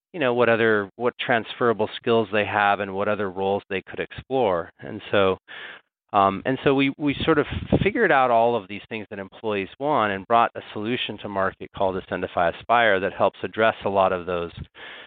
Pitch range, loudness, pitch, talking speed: 95-115 Hz, -23 LUFS, 105 Hz, 200 wpm